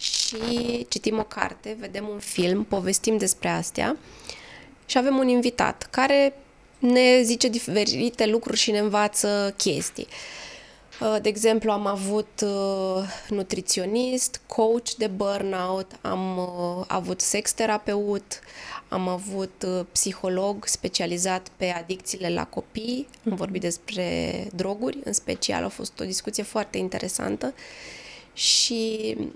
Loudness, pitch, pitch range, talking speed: -25 LUFS, 210 Hz, 190-225 Hz, 115 wpm